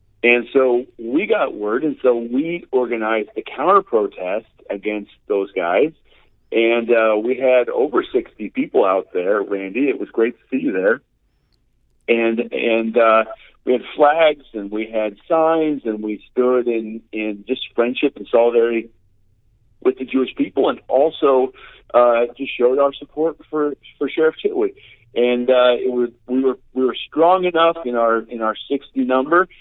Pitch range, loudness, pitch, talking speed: 115-145 Hz, -18 LUFS, 125 Hz, 165 wpm